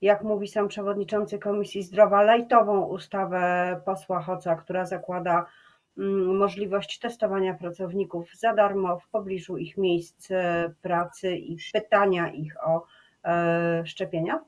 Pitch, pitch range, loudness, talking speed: 190 Hz, 175-205 Hz, -26 LUFS, 110 wpm